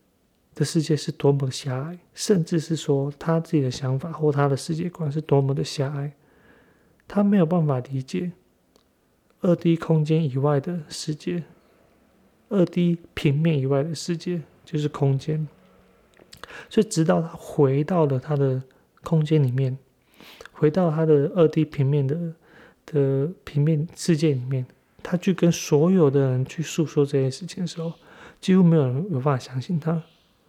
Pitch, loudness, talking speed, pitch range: 155 Hz, -23 LUFS, 230 characters per minute, 140-170 Hz